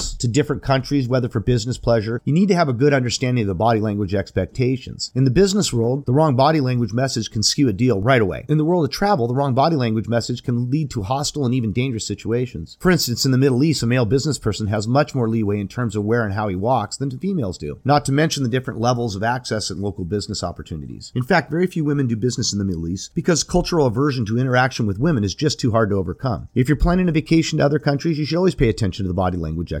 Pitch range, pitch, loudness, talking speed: 110-145 Hz, 125 Hz, -20 LUFS, 265 wpm